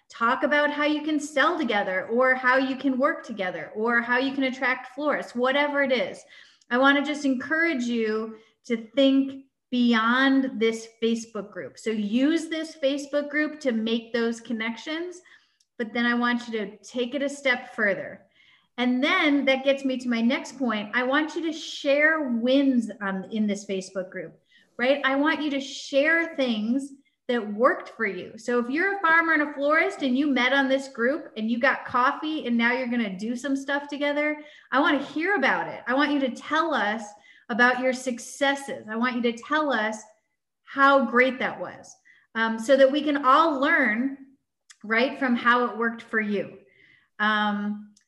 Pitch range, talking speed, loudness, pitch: 230-285 Hz, 190 wpm, -24 LUFS, 260 Hz